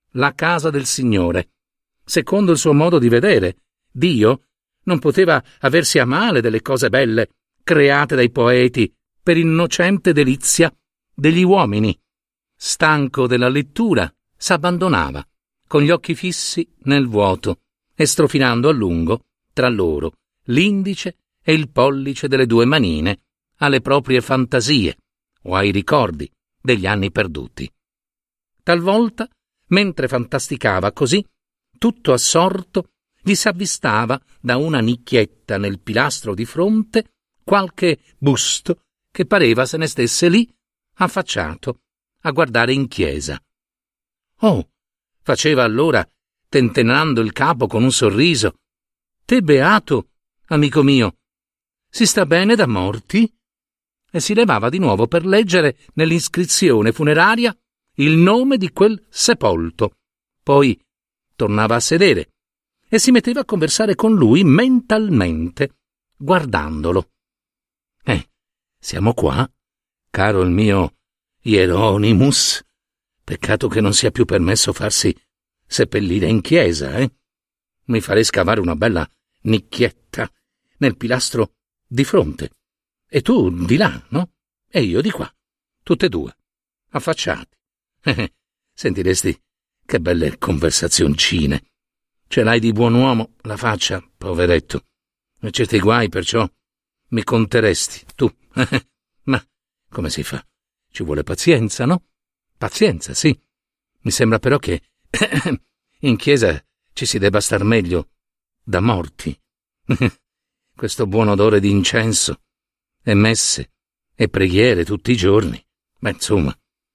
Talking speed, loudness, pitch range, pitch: 120 wpm, -17 LUFS, 110-170 Hz, 135 Hz